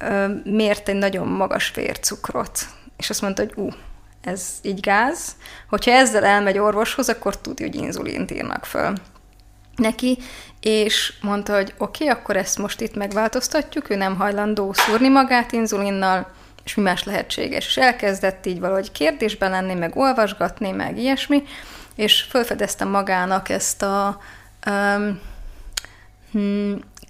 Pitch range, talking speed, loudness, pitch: 195-225 Hz, 135 wpm, -21 LUFS, 205 Hz